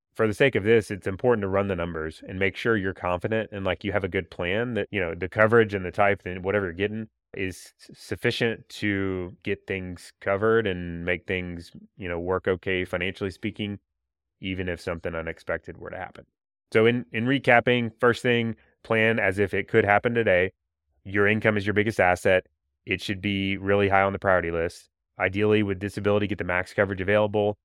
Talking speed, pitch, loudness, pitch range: 200 wpm, 100 Hz, -25 LUFS, 90-110 Hz